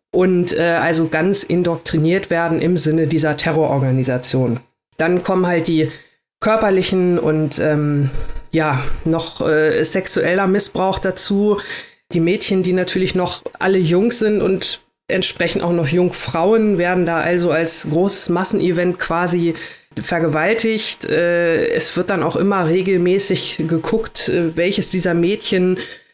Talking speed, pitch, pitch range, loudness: 125 wpm, 175 Hz, 165-190 Hz, -17 LUFS